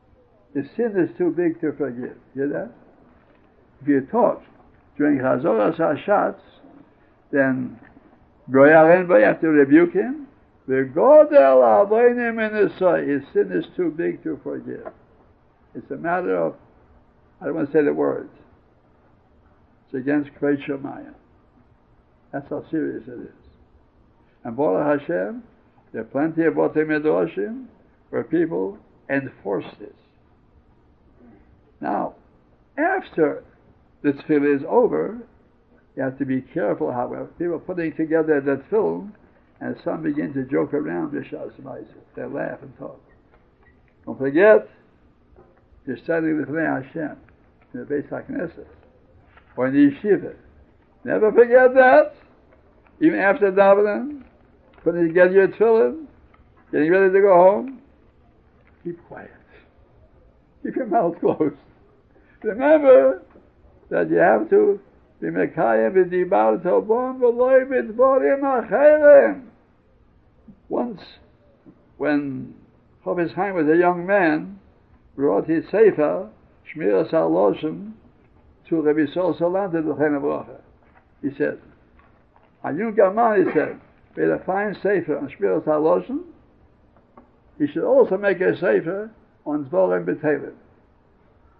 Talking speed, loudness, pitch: 120 wpm, -20 LUFS, 170 Hz